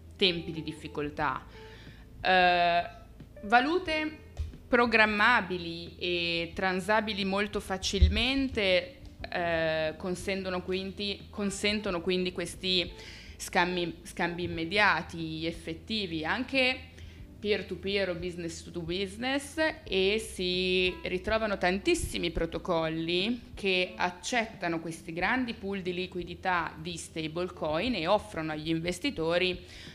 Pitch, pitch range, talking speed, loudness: 180 Hz, 170-205 Hz, 85 wpm, -30 LUFS